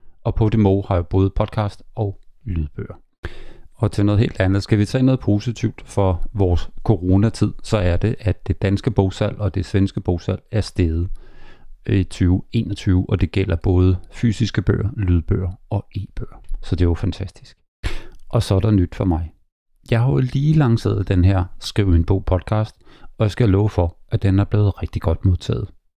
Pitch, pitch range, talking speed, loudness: 100 Hz, 90-110 Hz, 190 wpm, -20 LUFS